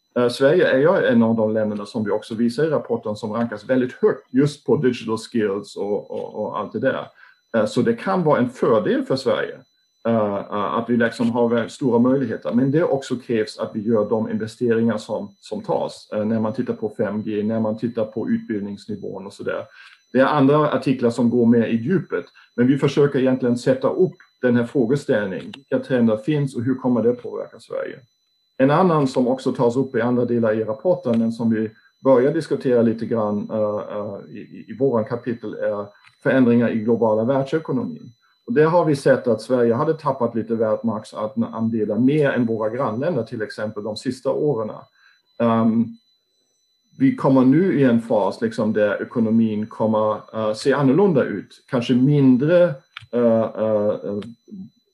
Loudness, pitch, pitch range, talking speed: -20 LUFS, 120 Hz, 110-140 Hz, 175 wpm